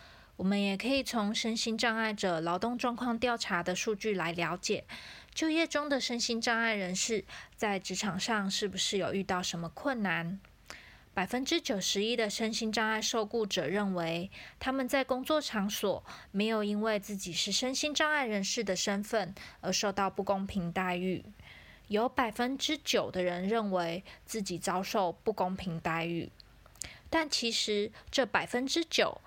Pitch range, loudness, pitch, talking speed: 185-235 Hz, -32 LUFS, 210 Hz, 245 characters per minute